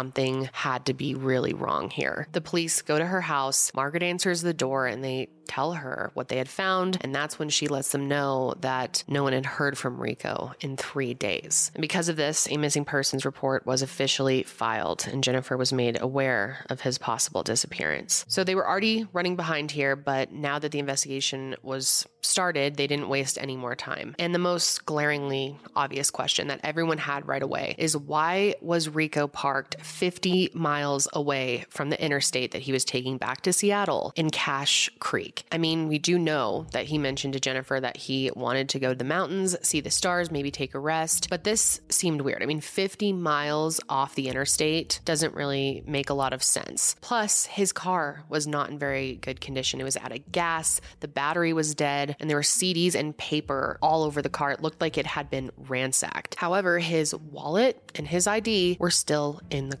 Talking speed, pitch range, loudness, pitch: 205 wpm, 135-165 Hz, -26 LUFS, 145 Hz